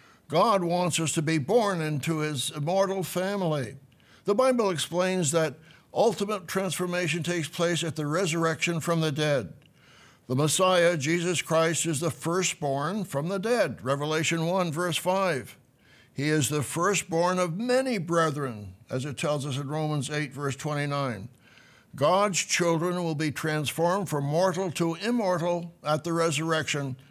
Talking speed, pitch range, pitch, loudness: 145 wpm, 150-180 Hz, 165 Hz, -27 LUFS